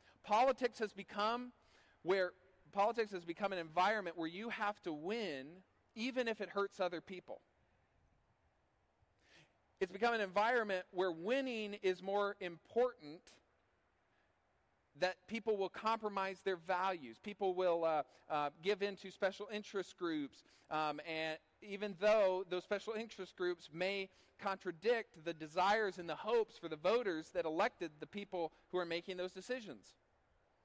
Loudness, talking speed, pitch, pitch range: -40 LUFS, 140 wpm, 190 Hz, 170-215 Hz